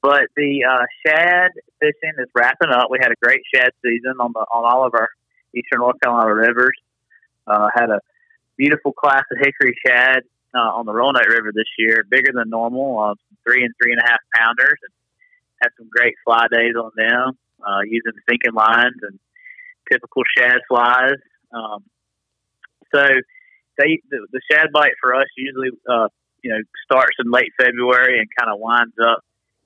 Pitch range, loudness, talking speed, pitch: 115-150 Hz, -16 LUFS, 180 wpm, 125 Hz